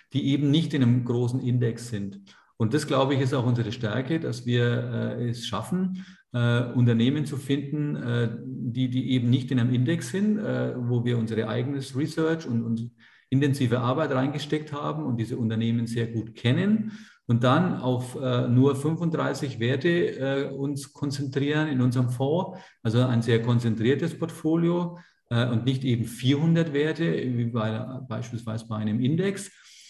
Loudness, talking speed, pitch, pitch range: -26 LUFS, 165 wpm, 130 Hz, 120-145 Hz